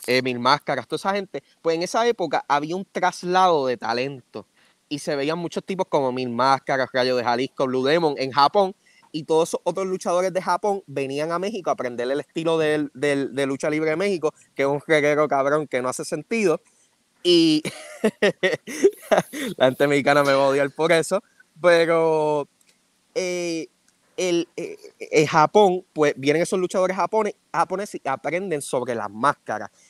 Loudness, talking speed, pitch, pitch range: -22 LUFS, 175 wpm, 160 Hz, 140-190 Hz